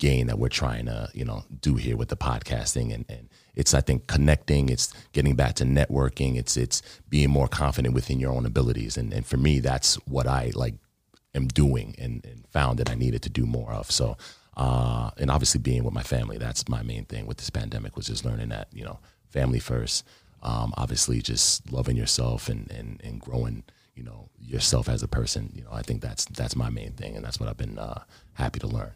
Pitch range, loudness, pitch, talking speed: 60-80 Hz, -26 LUFS, 65 Hz, 225 wpm